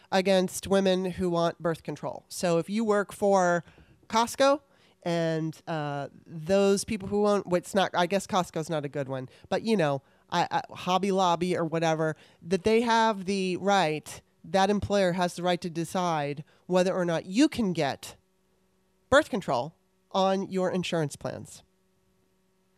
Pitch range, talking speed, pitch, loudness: 160-195 Hz, 160 wpm, 180 Hz, -27 LUFS